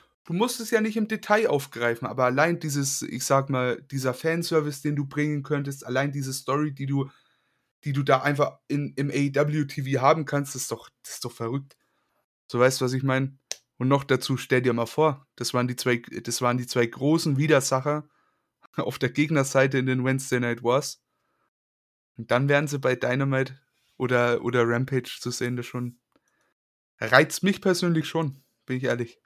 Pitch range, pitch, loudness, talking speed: 125-145 Hz, 135 Hz, -25 LUFS, 190 wpm